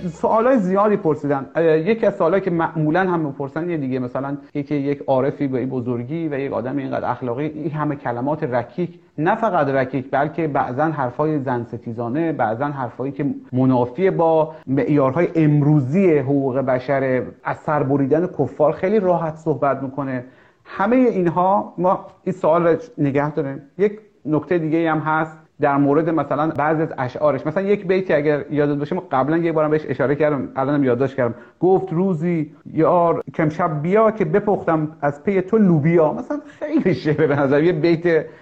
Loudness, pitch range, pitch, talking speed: -20 LUFS, 140-175 Hz, 155 Hz, 165 wpm